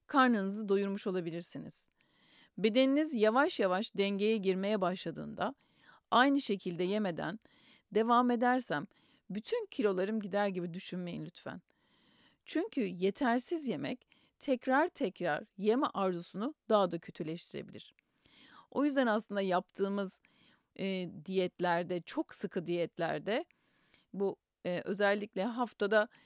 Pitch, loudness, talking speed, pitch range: 205 Hz, -34 LUFS, 100 wpm, 185-245 Hz